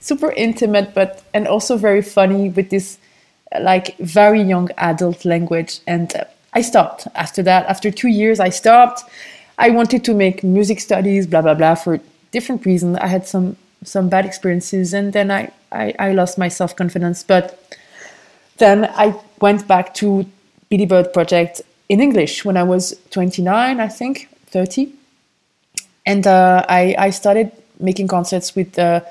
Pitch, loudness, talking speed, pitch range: 195 Hz, -15 LUFS, 160 wpm, 180-210 Hz